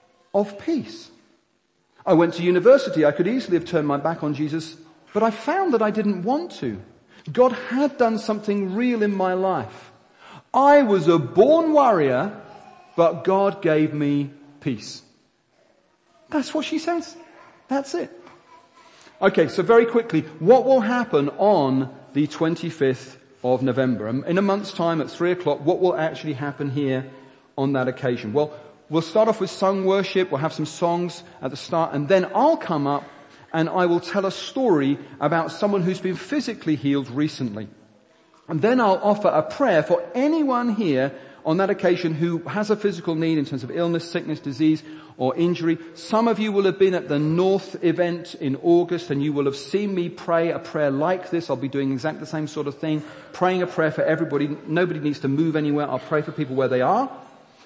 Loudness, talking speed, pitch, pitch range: -22 LUFS, 185 wpm, 170 Hz, 145-200 Hz